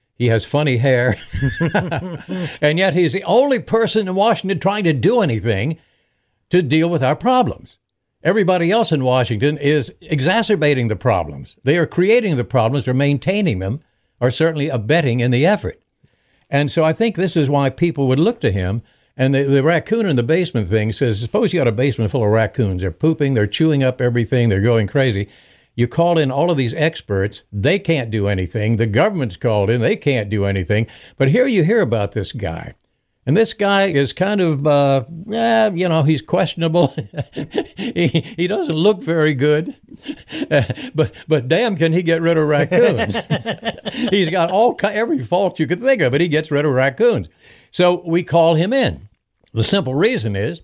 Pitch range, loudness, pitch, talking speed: 125-180 Hz, -17 LUFS, 150 Hz, 185 wpm